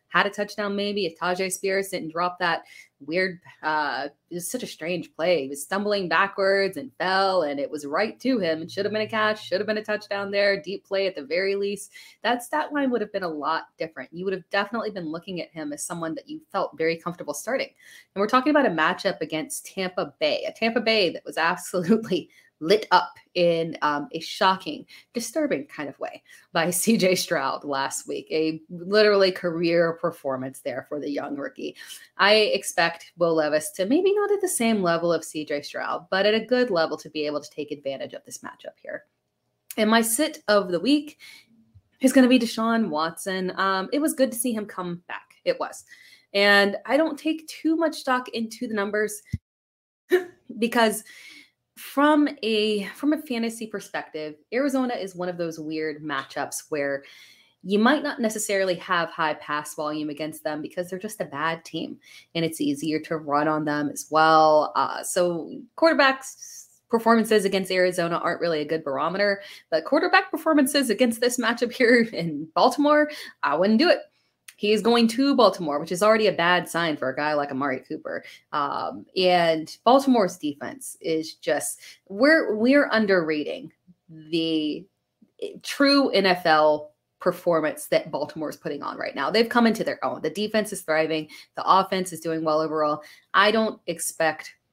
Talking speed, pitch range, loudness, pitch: 185 wpm, 160-230 Hz, -24 LUFS, 190 Hz